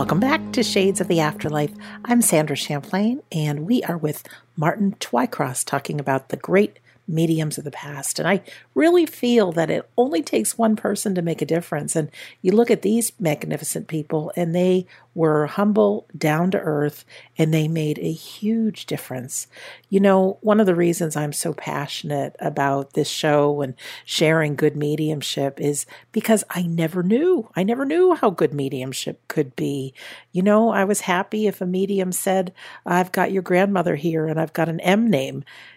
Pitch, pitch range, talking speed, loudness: 175 Hz, 150-205 Hz, 180 wpm, -21 LUFS